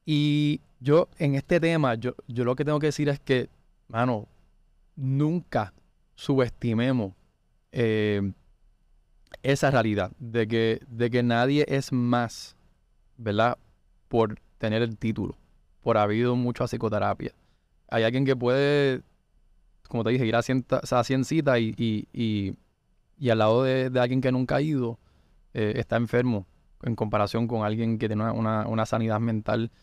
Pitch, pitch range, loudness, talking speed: 120 Hz, 110-130 Hz, -26 LUFS, 150 wpm